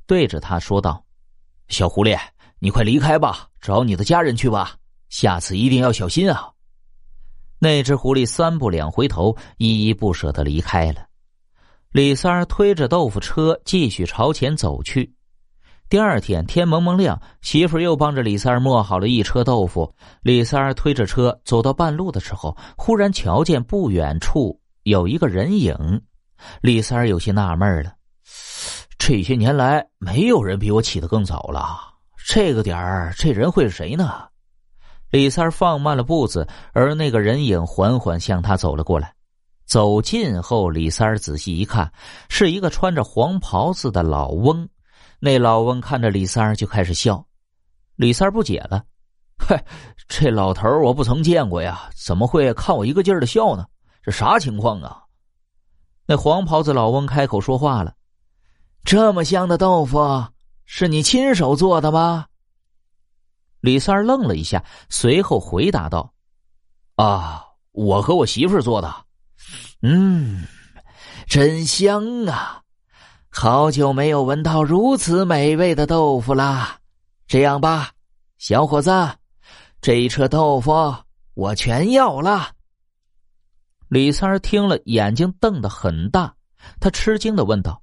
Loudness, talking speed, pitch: -18 LUFS, 215 characters per minute, 120 Hz